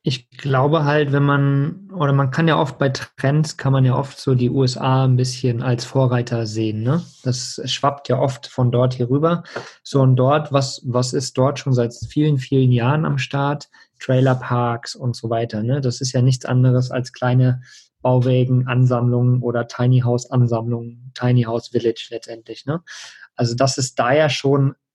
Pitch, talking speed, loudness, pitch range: 130 Hz, 185 wpm, -19 LUFS, 125-140 Hz